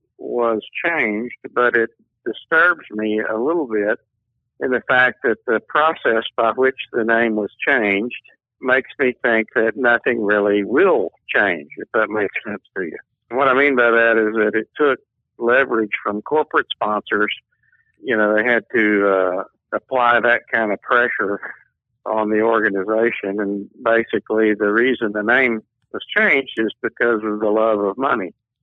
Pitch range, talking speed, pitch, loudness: 105-120 Hz, 165 wpm, 110 Hz, -18 LUFS